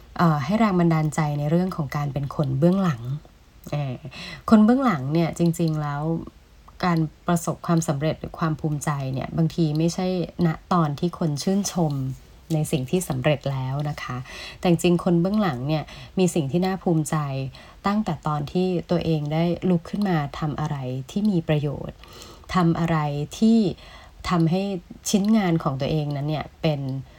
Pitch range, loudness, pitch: 150-180 Hz, -24 LUFS, 165 Hz